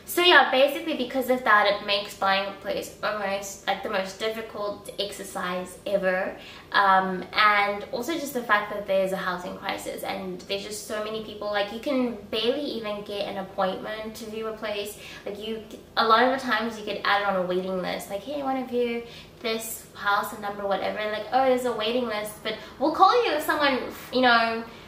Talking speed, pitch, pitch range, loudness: 210 wpm, 210 Hz, 200-240 Hz, -25 LUFS